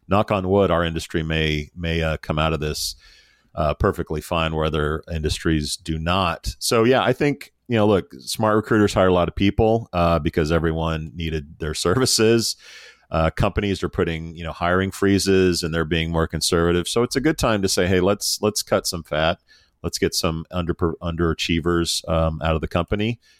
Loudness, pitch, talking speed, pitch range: -21 LUFS, 85 Hz, 195 wpm, 80-100 Hz